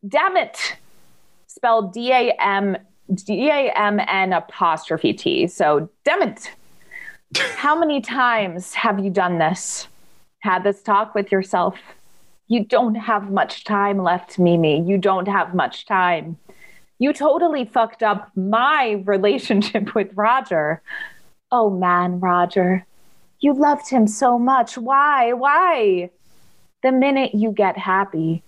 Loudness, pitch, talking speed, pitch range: -19 LUFS, 210 Hz, 130 wpm, 190-255 Hz